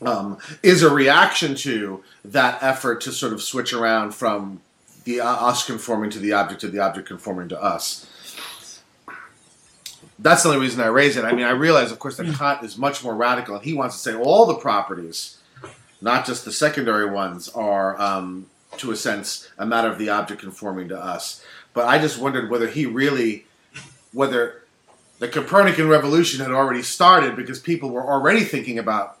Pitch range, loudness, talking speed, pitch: 105-140 Hz, -20 LUFS, 185 wpm, 120 Hz